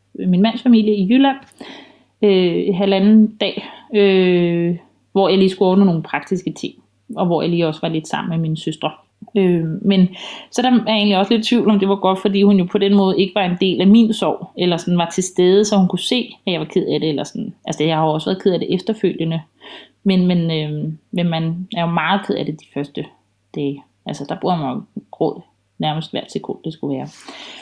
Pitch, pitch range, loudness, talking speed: 185 Hz, 165-205 Hz, -17 LUFS, 240 wpm